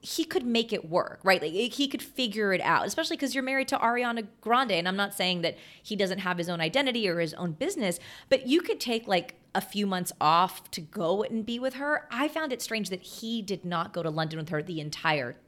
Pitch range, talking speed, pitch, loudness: 175-255 Hz, 250 wpm, 205 Hz, -29 LUFS